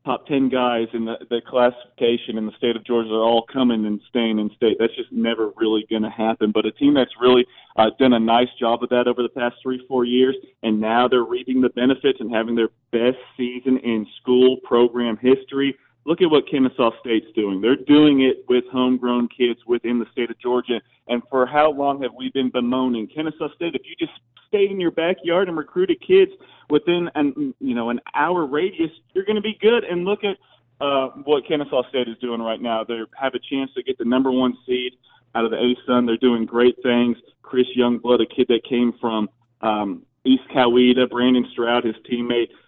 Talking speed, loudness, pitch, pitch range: 215 wpm, -20 LUFS, 125 Hz, 120-140 Hz